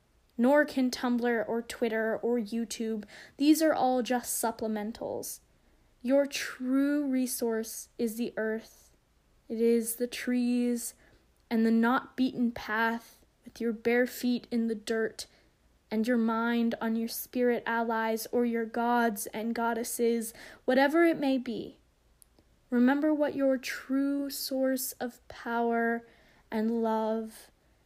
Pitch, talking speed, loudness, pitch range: 235 Hz, 125 wpm, -30 LUFS, 225-255 Hz